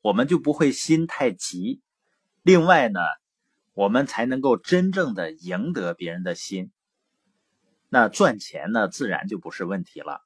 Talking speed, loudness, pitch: 215 characters per minute, -23 LUFS, 165 Hz